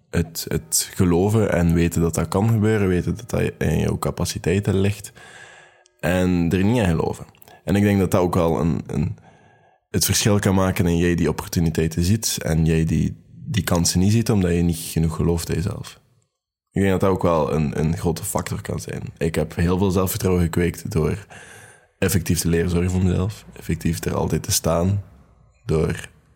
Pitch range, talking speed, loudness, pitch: 85-95 Hz, 190 wpm, -21 LUFS, 90 Hz